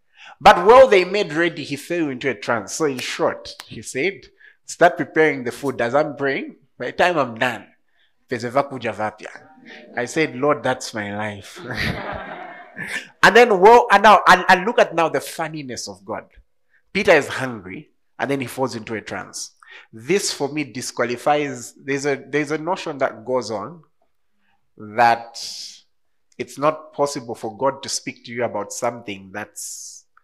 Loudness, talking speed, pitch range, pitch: -19 LUFS, 165 wpm, 115-155 Hz, 135 Hz